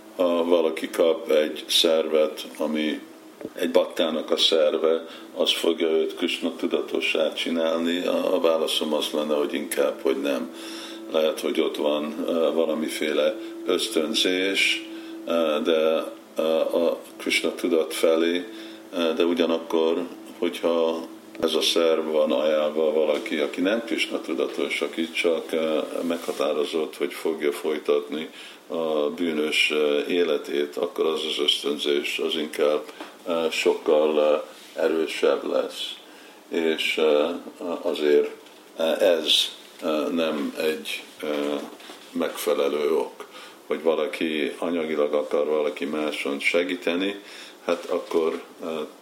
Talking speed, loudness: 100 wpm, -24 LUFS